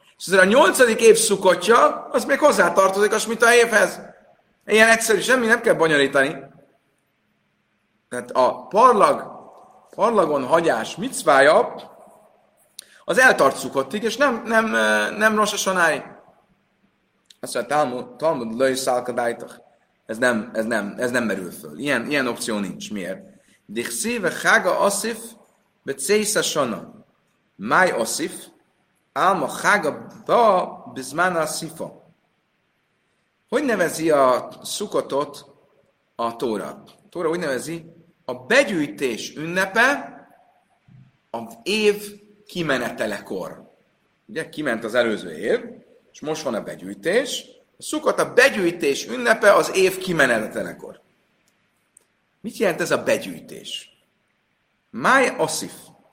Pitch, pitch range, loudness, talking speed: 195 Hz, 140-225 Hz, -20 LUFS, 105 wpm